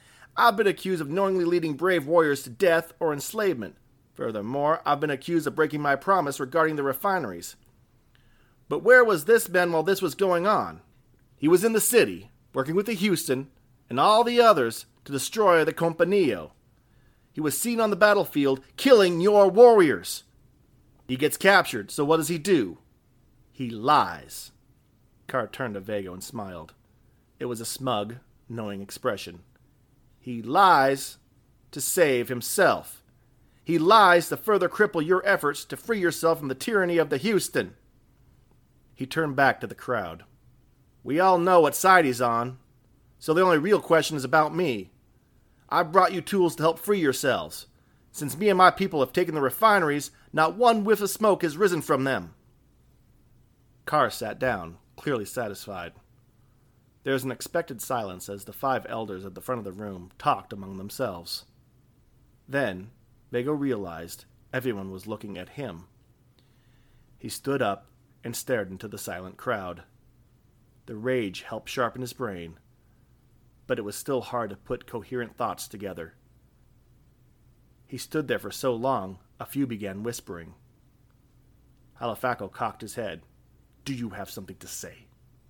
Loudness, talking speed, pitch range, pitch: -24 LUFS, 160 wpm, 120-165 Hz, 130 Hz